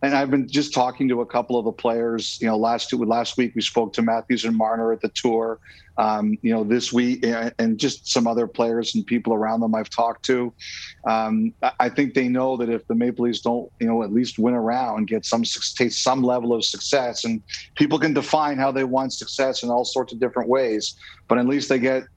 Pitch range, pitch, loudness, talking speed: 115-130 Hz, 120 Hz, -22 LUFS, 235 wpm